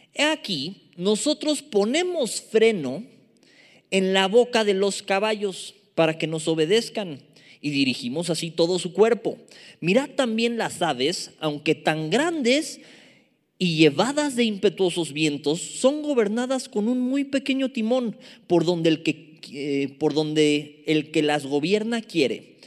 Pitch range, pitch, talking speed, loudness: 160-250 Hz, 200 Hz, 135 wpm, -23 LUFS